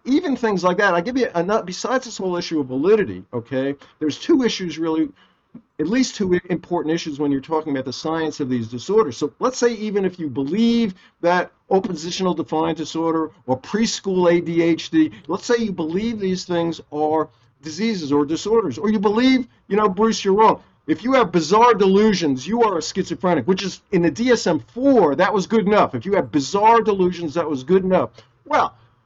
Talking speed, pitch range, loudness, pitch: 195 wpm, 160-220 Hz, -20 LUFS, 180 Hz